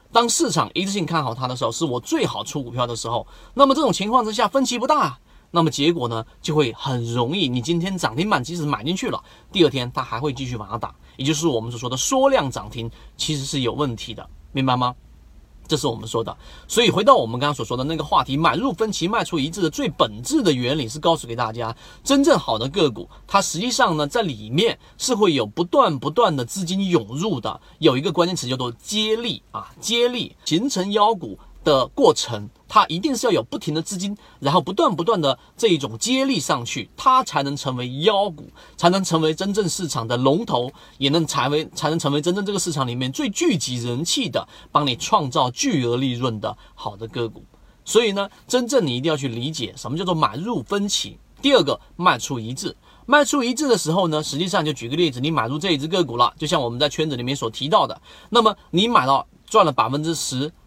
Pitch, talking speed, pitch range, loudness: 155 Hz, 330 characters per minute, 125-190 Hz, -21 LUFS